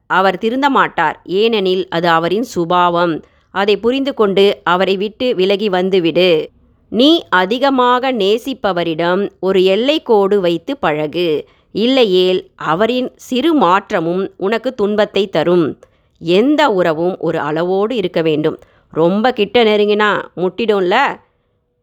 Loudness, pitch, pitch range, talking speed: -14 LUFS, 195 Hz, 175-230 Hz, 105 wpm